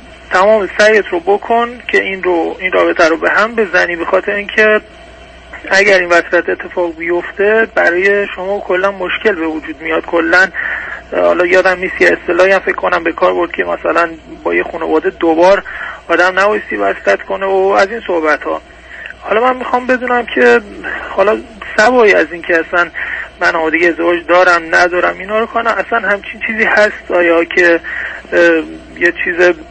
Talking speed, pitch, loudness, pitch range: 165 wpm, 185 Hz, -12 LUFS, 170-210 Hz